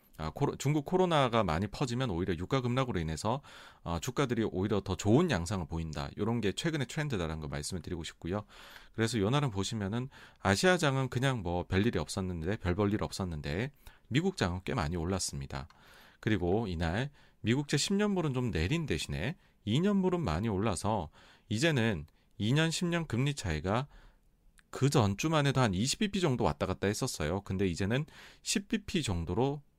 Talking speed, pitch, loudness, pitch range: 340 characters per minute, 110 Hz, -32 LUFS, 90-135 Hz